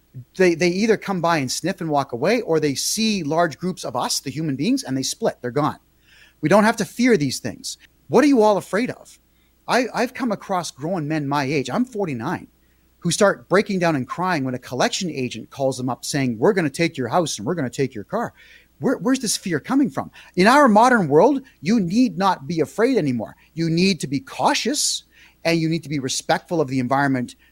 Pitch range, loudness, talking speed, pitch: 140-205 Hz, -20 LUFS, 230 wpm, 165 Hz